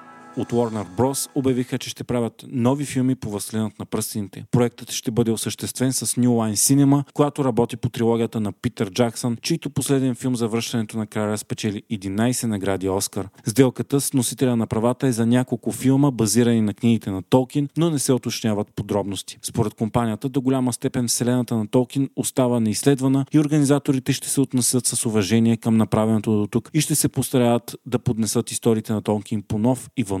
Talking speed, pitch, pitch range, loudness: 185 wpm, 120 Hz, 110-130 Hz, -22 LUFS